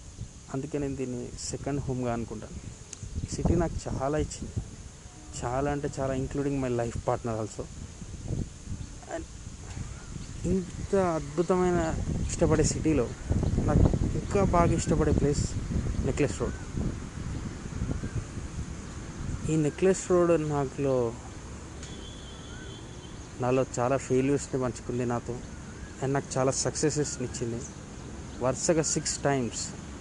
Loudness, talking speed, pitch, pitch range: -29 LUFS, 95 wpm, 125 Hz, 110-140 Hz